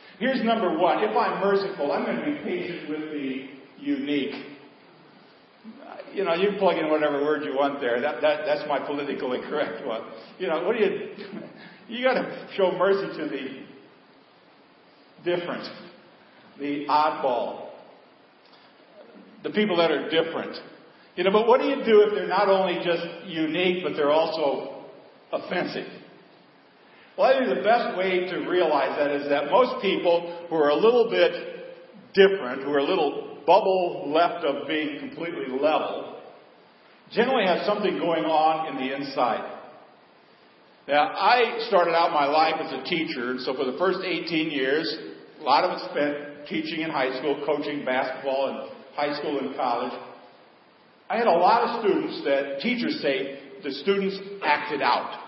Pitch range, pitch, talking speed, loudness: 145-200 Hz, 170 Hz, 165 wpm, -24 LUFS